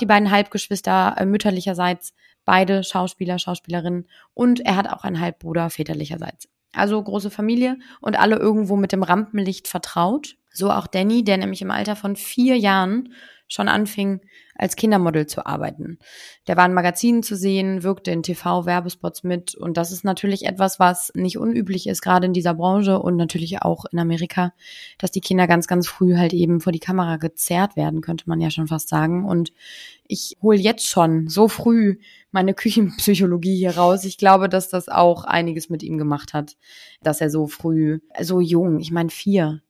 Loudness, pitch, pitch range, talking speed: -20 LUFS, 185 Hz, 170-200 Hz, 175 wpm